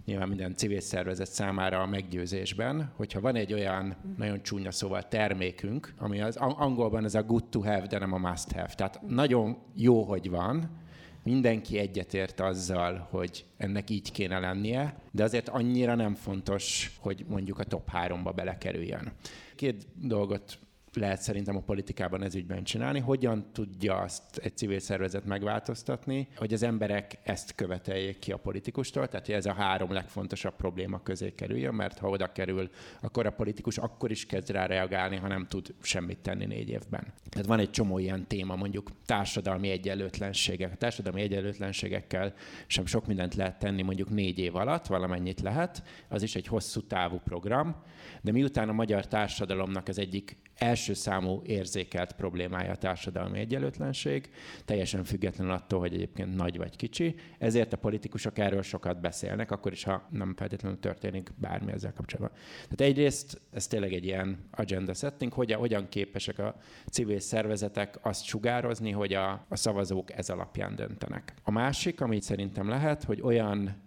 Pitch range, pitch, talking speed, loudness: 95-110 Hz, 100 Hz, 165 wpm, -32 LUFS